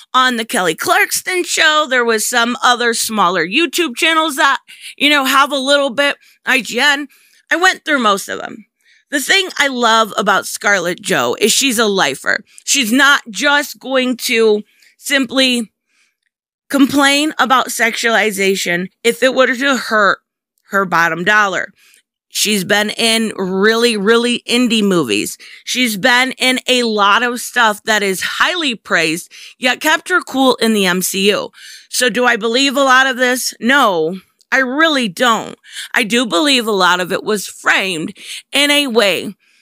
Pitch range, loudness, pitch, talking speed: 215-275 Hz, -13 LUFS, 245 Hz, 155 wpm